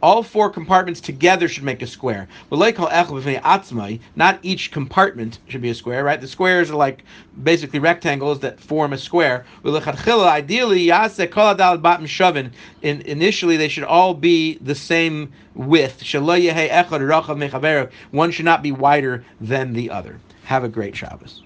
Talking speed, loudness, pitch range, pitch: 130 wpm, -18 LUFS, 130-170 Hz, 150 Hz